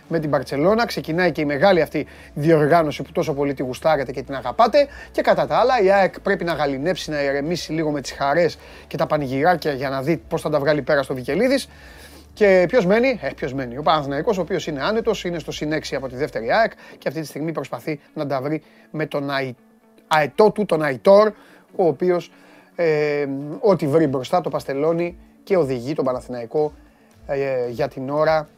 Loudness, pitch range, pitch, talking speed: -20 LUFS, 140-175 Hz, 155 Hz, 200 wpm